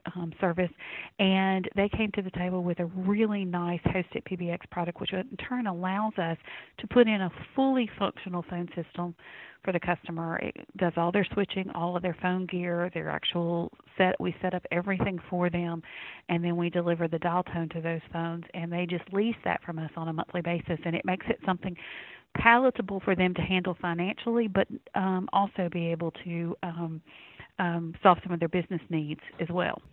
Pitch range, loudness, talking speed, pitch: 170-190 Hz, -30 LUFS, 195 wpm, 180 Hz